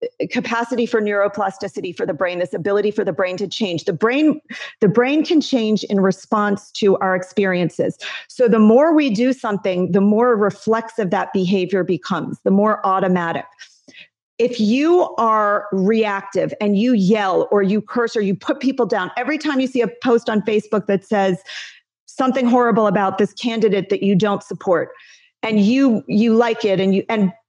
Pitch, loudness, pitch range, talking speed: 215 Hz, -18 LUFS, 195-240 Hz, 175 wpm